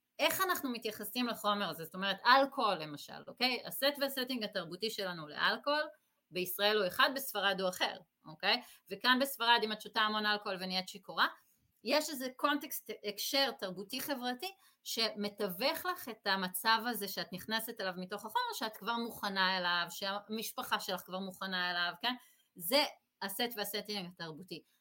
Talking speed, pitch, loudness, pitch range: 150 wpm, 215 Hz, -34 LUFS, 195-255 Hz